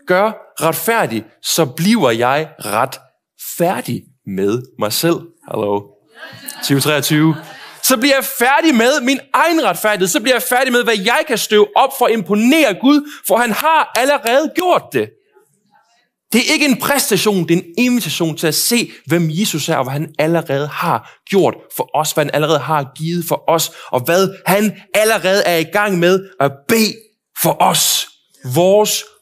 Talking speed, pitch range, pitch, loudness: 170 wpm, 155-240 Hz, 190 Hz, -15 LUFS